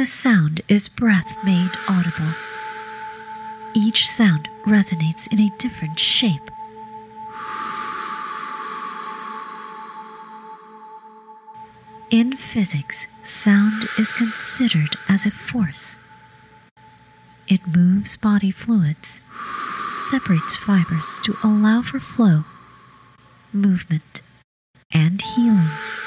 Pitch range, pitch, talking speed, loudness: 185-225 Hz, 220 Hz, 80 wpm, -19 LUFS